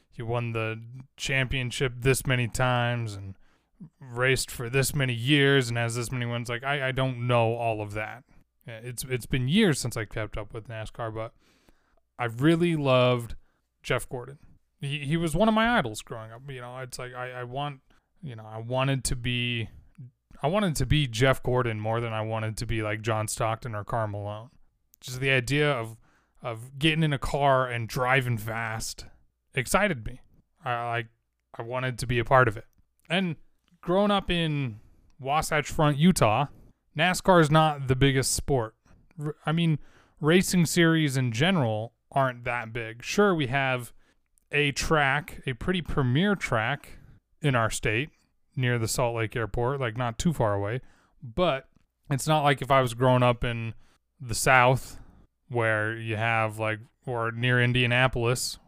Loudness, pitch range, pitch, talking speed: -26 LUFS, 115-140 Hz, 125 Hz, 175 wpm